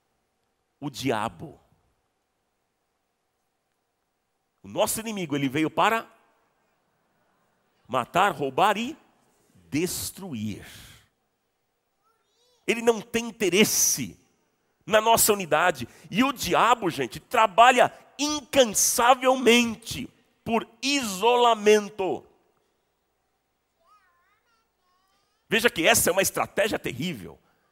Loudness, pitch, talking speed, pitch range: -23 LUFS, 235 Hz, 75 wpm, 215-300 Hz